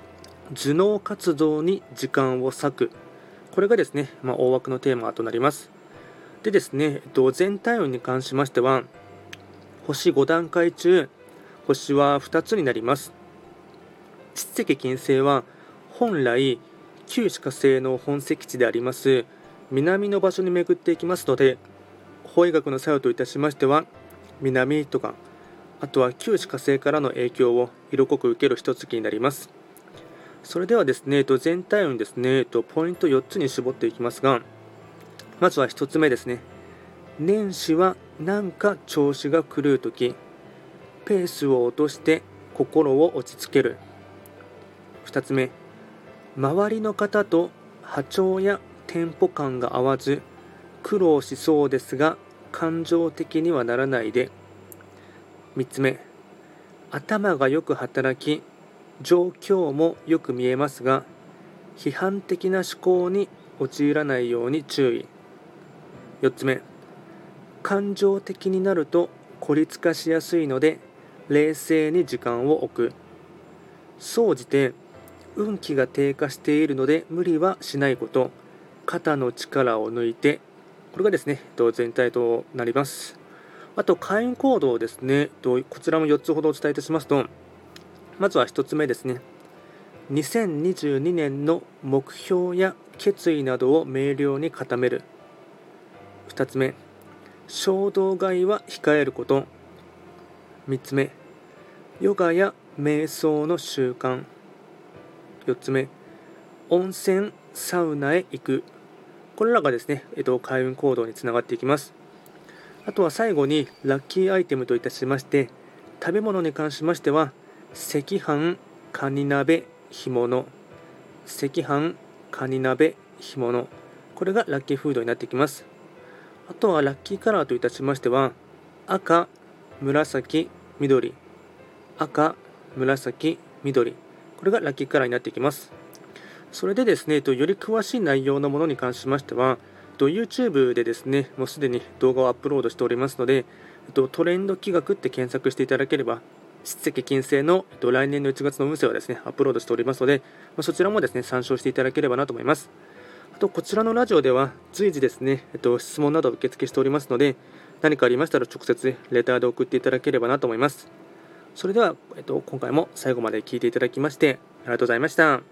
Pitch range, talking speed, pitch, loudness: 130-175 Hz, 275 characters per minute, 145 Hz, -23 LUFS